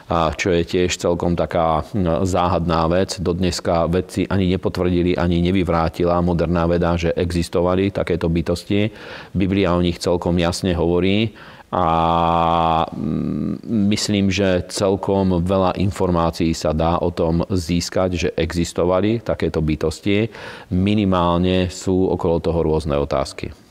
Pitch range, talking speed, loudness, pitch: 85-95 Hz, 120 wpm, -19 LUFS, 90 Hz